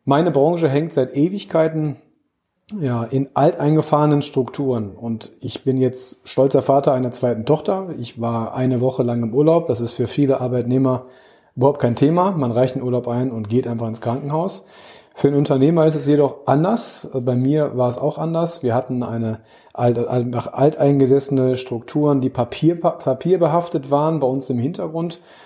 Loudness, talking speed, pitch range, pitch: -19 LUFS, 160 wpm, 125-150 Hz, 135 Hz